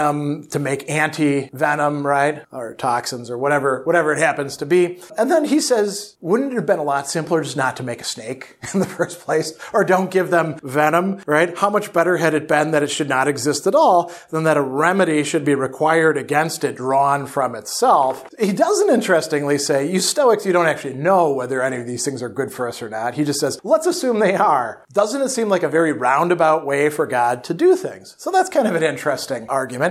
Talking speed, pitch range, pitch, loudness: 225 wpm, 140-185 Hz, 155 Hz, -18 LUFS